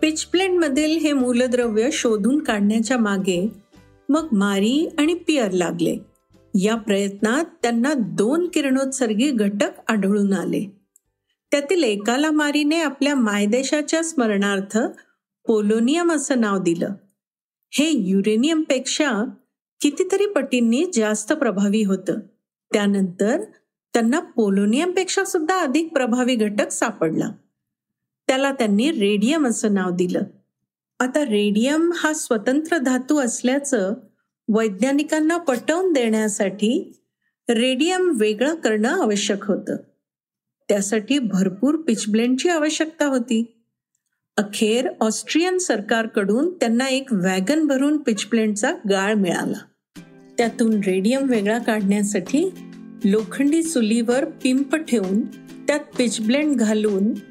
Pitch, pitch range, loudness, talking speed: 240 Hz, 215-295 Hz, -20 LUFS, 95 wpm